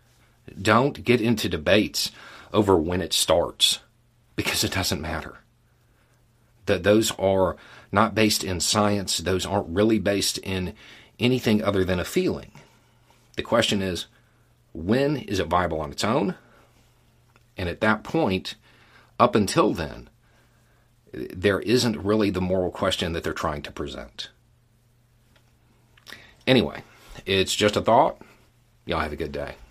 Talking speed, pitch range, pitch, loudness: 135 wpm, 95-115 Hz, 110 Hz, -23 LUFS